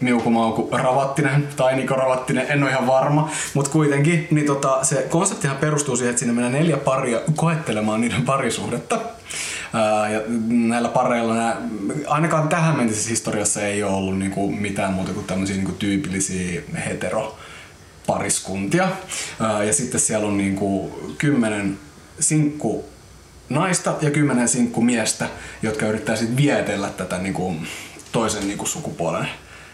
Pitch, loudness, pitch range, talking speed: 120 Hz, -21 LUFS, 105-145 Hz, 135 wpm